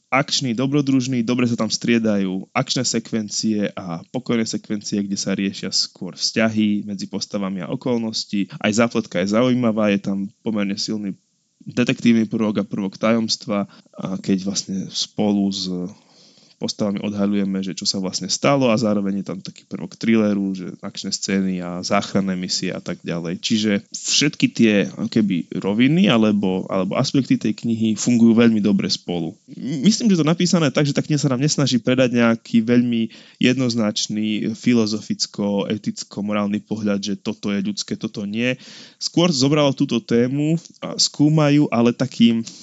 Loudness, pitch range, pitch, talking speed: -20 LUFS, 100-125 Hz, 110 Hz, 150 wpm